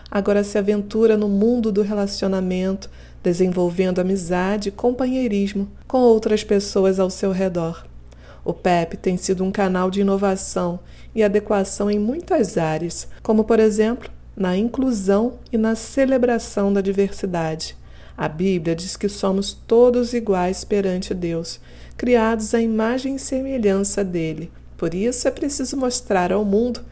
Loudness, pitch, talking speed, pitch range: -20 LUFS, 200 Hz, 140 wpm, 185-225 Hz